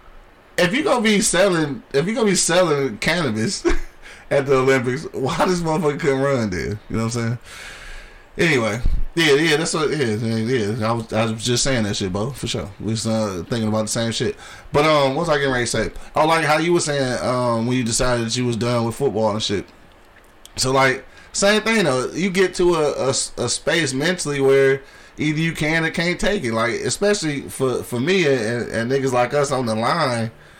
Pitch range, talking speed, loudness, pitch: 115-155 Hz, 225 wpm, -19 LUFS, 135 Hz